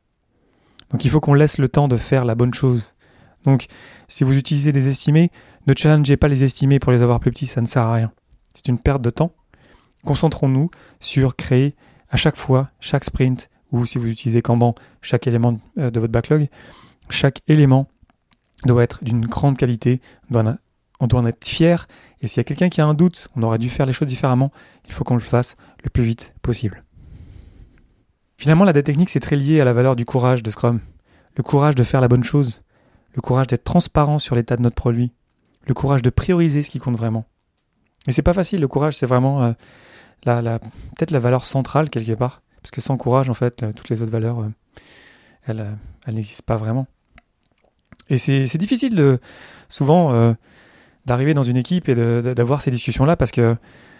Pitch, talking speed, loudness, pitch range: 125 Hz, 205 wpm, -19 LUFS, 120-145 Hz